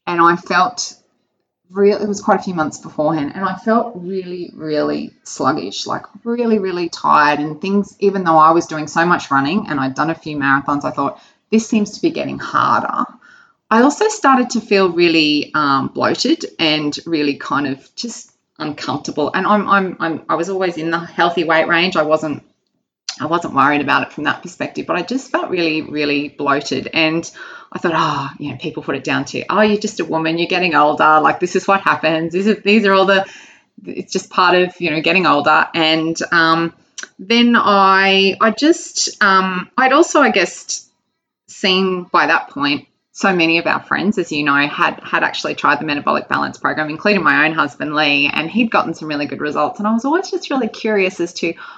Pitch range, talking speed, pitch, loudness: 155-210 Hz, 205 wpm, 180 Hz, -16 LUFS